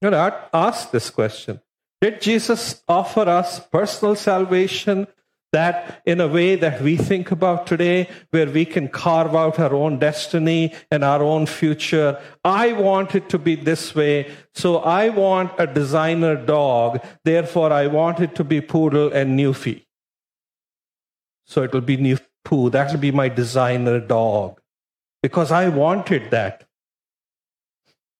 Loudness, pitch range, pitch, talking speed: -19 LUFS, 145-180 Hz, 160 Hz, 145 wpm